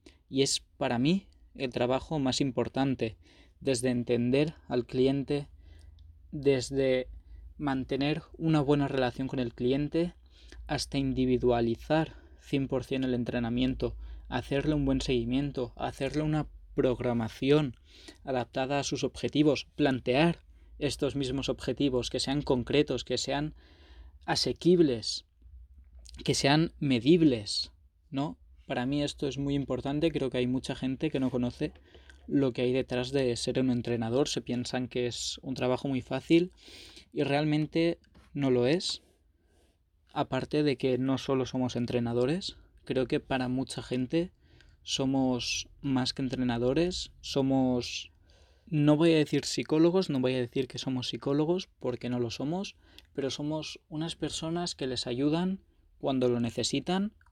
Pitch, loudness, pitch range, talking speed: 130 Hz, -30 LUFS, 120-145 Hz, 135 wpm